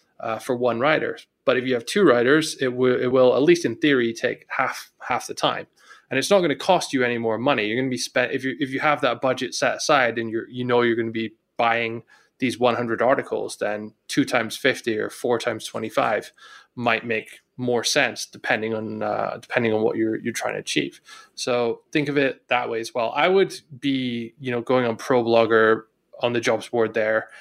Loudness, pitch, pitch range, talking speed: -22 LUFS, 120 Hz, 115-135 Hz, 230 wpm